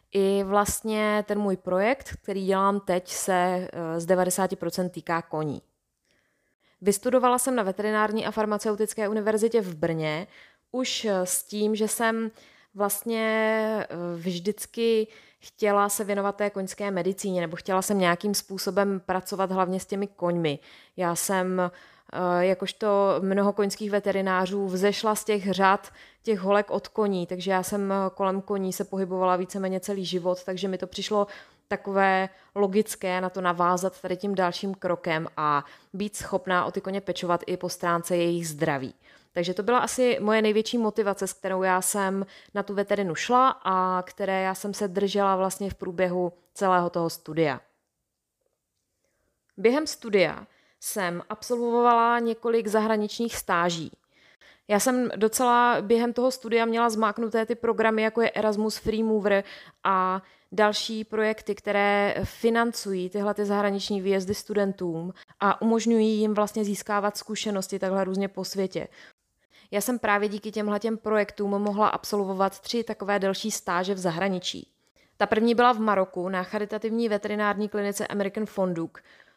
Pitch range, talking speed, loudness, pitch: 185-215 Hz, 145 wpm, -26 LUFS, 200 Hz